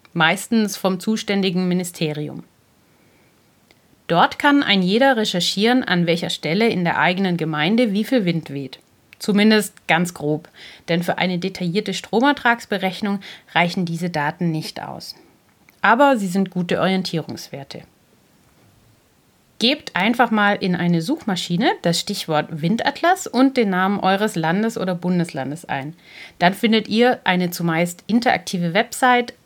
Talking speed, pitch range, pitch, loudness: 125 wpm, 170-220 Hz, 185 Hz, -19 LUFS